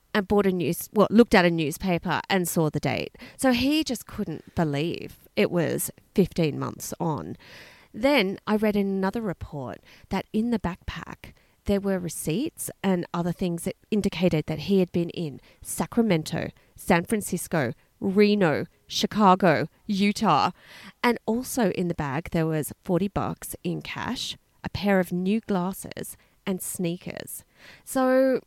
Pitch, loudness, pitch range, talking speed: 190 Hz, -25 LUFS, 170-210 Hz, 150 wpm